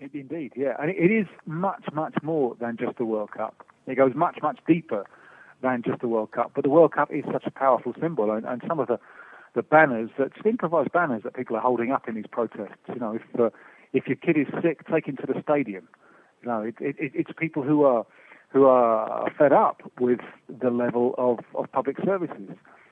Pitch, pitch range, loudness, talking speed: 135 Hz, 120-160 Hz, -25 LUFS, 225 wpm